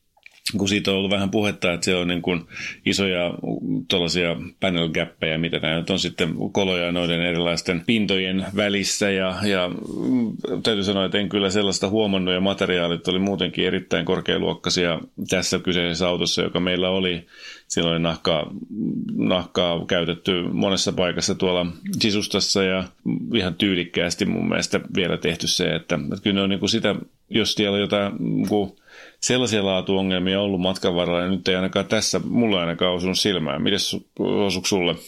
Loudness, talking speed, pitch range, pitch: -22 LUFS, 155 wpm, 90-100 Hz, 95 Hz